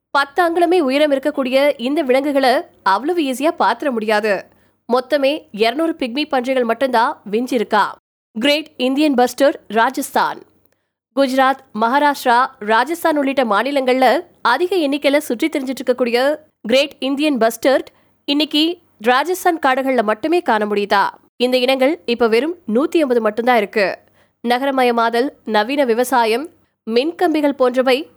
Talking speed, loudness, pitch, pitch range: 110 wpm, -17 LUFS, 265 Hz, 240-295 Hz